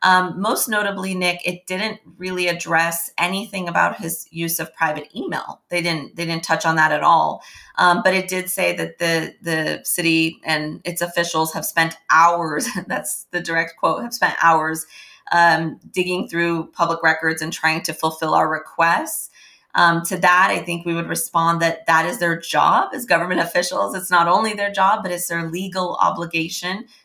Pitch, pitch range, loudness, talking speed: 170 Hz, 165-180 Hz, -19 LUFS, 185 wpm